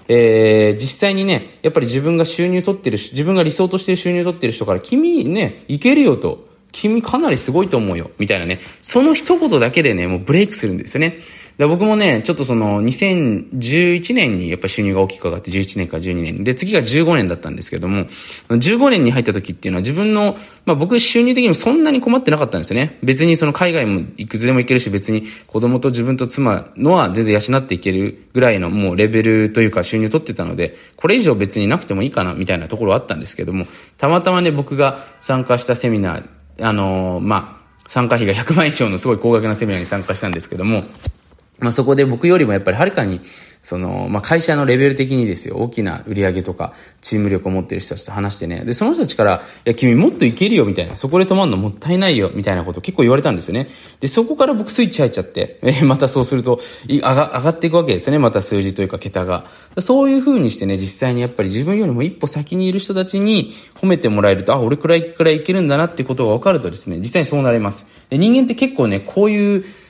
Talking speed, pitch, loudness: 465 characters per minute, 125 Hz, -16 LUFS